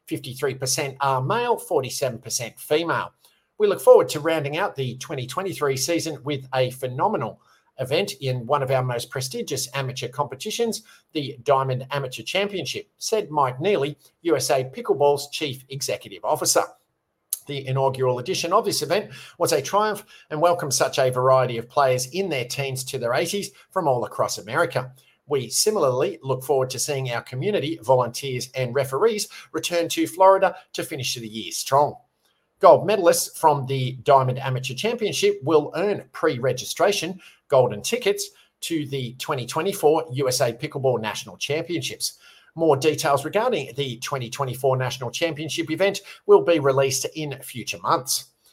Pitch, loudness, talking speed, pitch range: 140 Hz, -23 LUFS, 145 wpm, 130-170 Hz